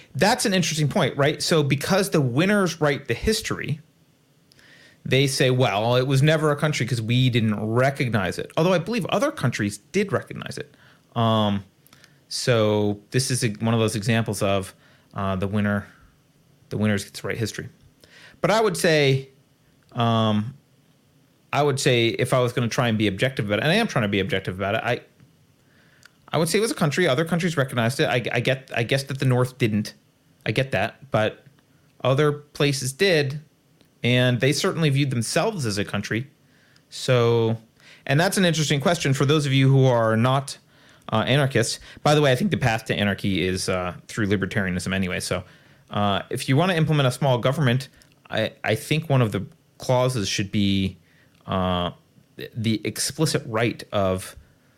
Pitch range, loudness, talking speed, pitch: 110-145 Hz, -22 LUFS, 185 wpm, 130 Hz